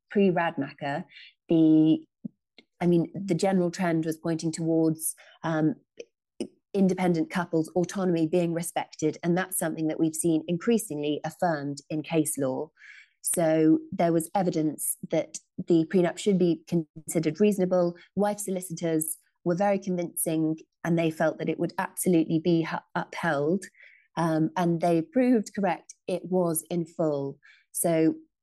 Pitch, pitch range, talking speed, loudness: 170 Hz, 160-180 Hz, 135 wpm, -27 LUFS